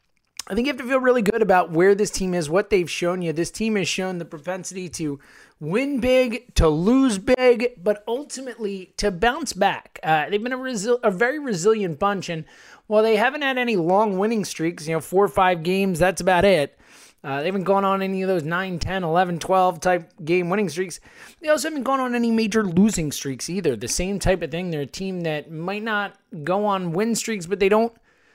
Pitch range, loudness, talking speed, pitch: 180-225 Hz, -22 LUFS, 220 wpm, 195 Hz